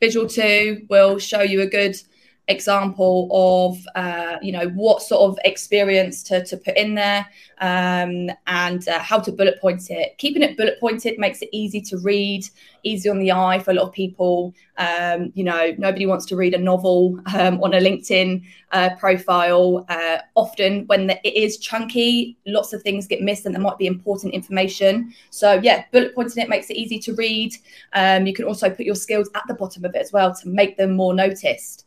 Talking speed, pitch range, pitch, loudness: 205 wpm, 185-210 Hz, 195 Hz, -19 LUFS